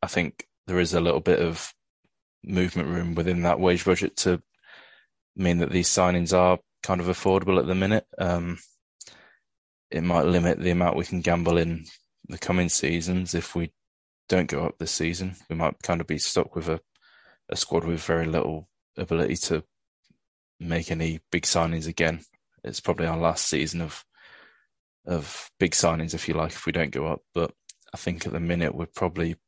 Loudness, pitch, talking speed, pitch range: -26 LUFS, 85 Hz, 185 wpm, 80-90 Hz